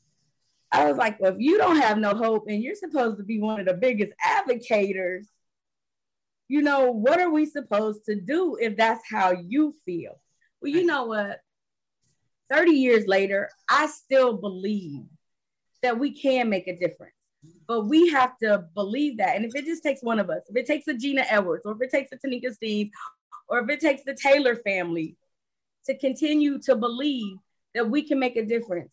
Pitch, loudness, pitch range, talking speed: 235 Hz, -24 LUFS, 205-280 Hz, 195 wpm